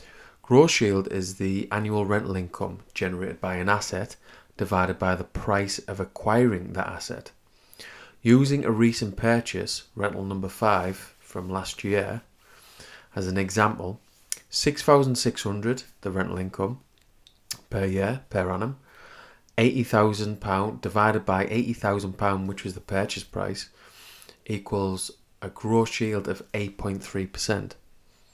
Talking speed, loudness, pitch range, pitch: 120 wpm, -26 LUFS, 95-110 Hz, 100 Hz